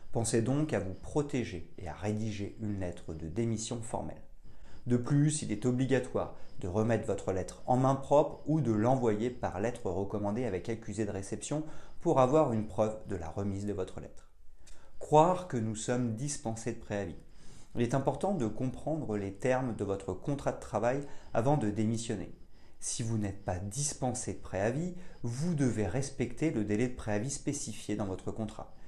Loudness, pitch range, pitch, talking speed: -33 LUFS, 105-135 Hz, 115 Hz, 175 wpm